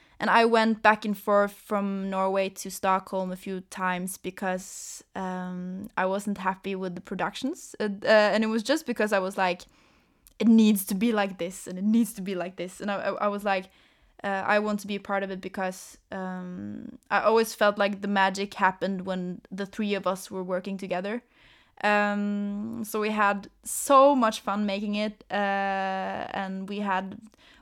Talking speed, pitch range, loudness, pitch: 190 wpm, 190-215 Hz, -27 LUFS, 200 Hz